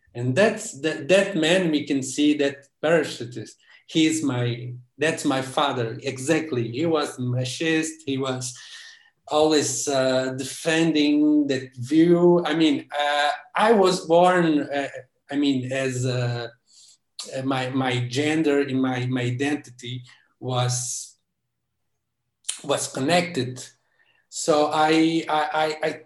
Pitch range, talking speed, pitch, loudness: 130-160 Hz, 120 wpm, 145 Hz, -22 LUFS